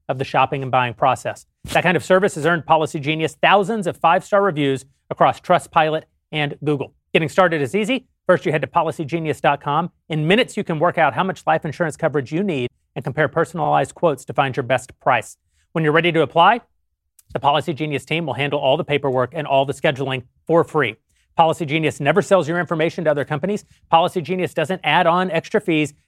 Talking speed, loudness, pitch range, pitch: 205 wpm, -19 LUFS, 145-175 Hz, 160 Hz